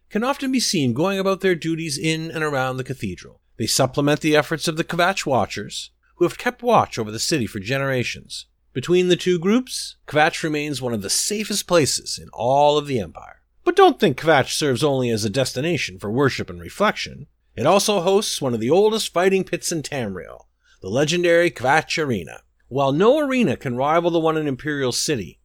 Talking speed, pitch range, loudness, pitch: 200 wpm, 125-180 Hz, -20 LUFS, 155 Hz